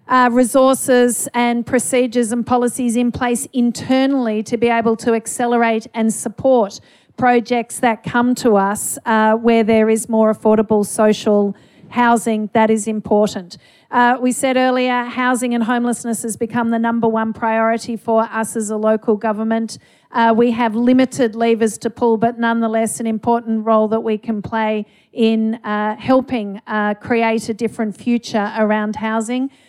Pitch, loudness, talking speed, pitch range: 230 Hz, -17 LUFS, 155 wpm, 220-245 Hz